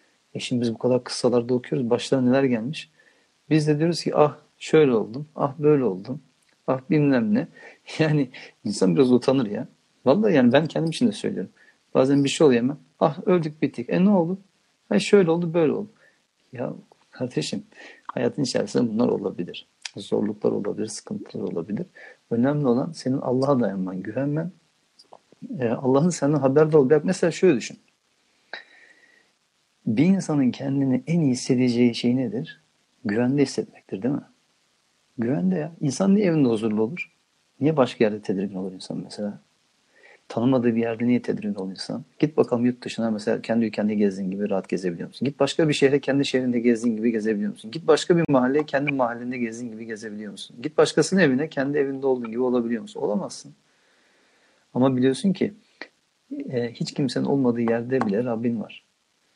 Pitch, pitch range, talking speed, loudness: 135 Hz, 120-160 Hz, 160 wpm, -23 LUFS